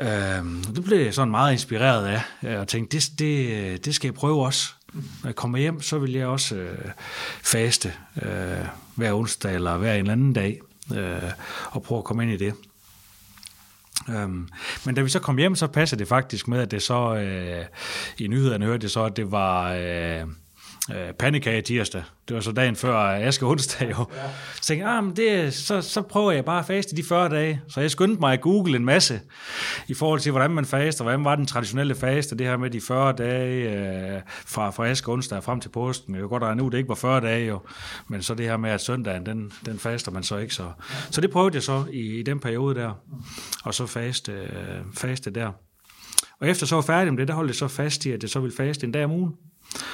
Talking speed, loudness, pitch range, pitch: 225 wpm, -25 LUFS, 105-140 Hz, 120 Hz